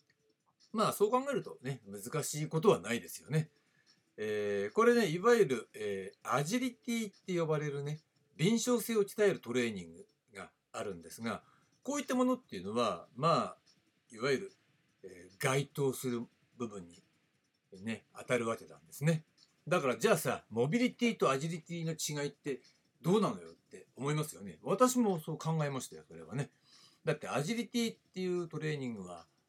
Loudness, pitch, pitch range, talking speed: -35 LUFS, 155 Hz, 130-210 Hz, 350 characters per minute